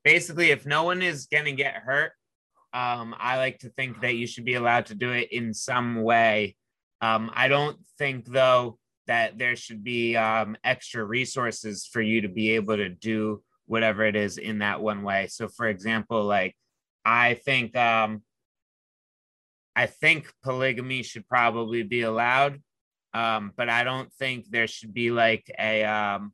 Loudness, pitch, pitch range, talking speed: -25 LUFS, 115 Hz, 110-125 Hz, 175 wpm